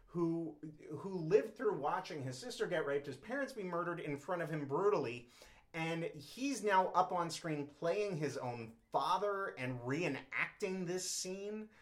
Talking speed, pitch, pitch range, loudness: 160 wpm, 170 Hz, 145-195 Hz, -39 LUFS